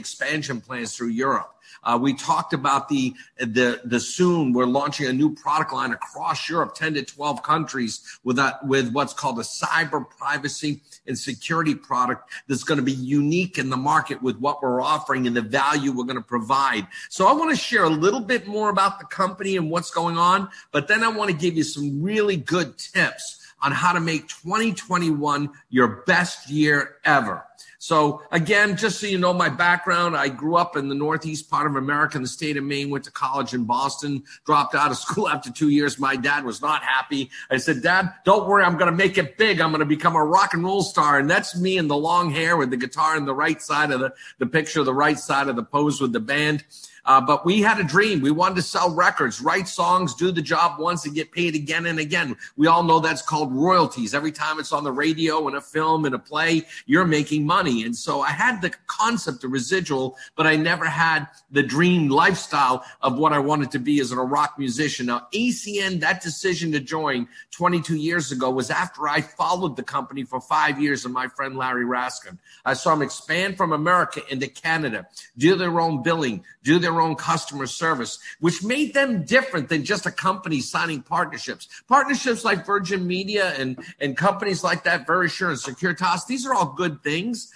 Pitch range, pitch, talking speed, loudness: 140-180 Hz, 155 Hz, 215 wpm, -22 LUFS